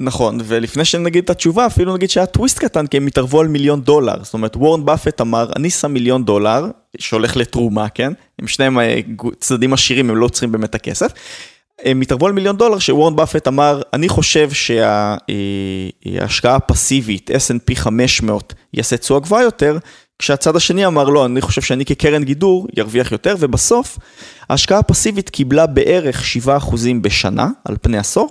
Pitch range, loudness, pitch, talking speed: 115-155 Hz, -14 LUFS, 135 Hz, 160 wpm